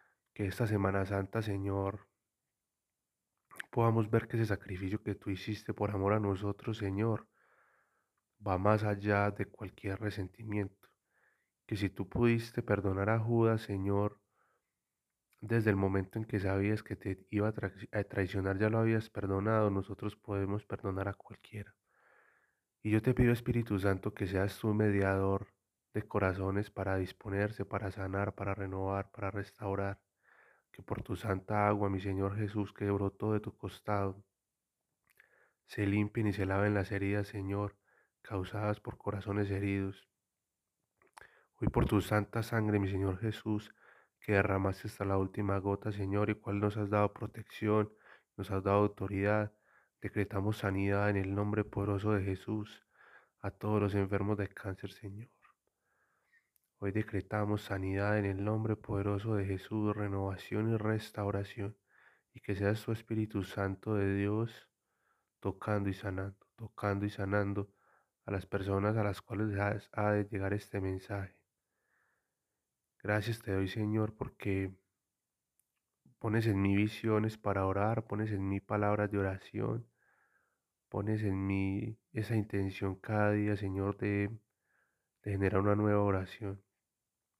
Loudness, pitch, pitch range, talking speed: -35 LUFS, 100 Hz, 100-105 Hz, 140 wpm